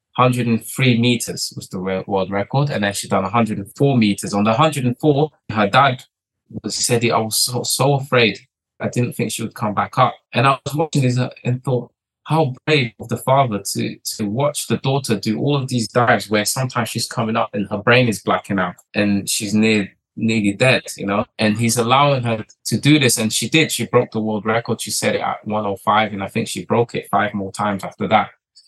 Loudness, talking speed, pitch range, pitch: -18 LUFS, 220 wpm, 105-130 Hz, 115 Hz